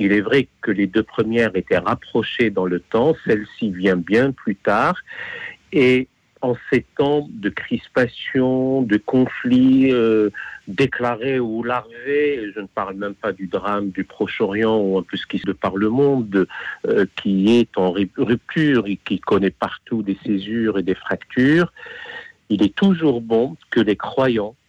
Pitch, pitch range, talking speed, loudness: 115 Hz, 100-130 Hz, 165 wpm, -19 LUFS